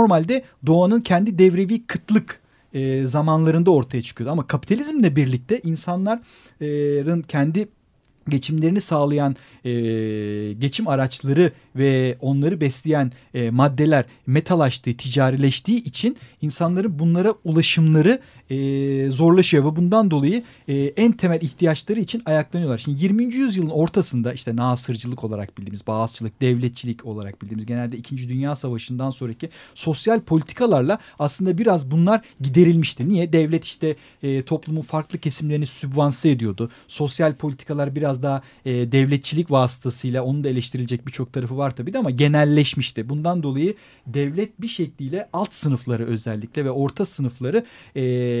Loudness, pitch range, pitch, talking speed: -21 LUFS, 130-170 Hz, 145 Hz, 130 wpm